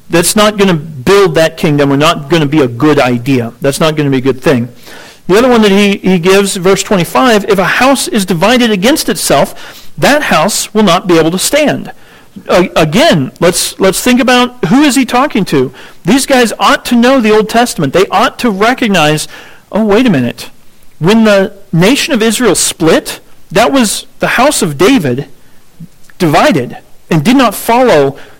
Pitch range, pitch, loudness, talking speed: 160-235 Hz, 195 Hz, -9 LUFS, 200 wpm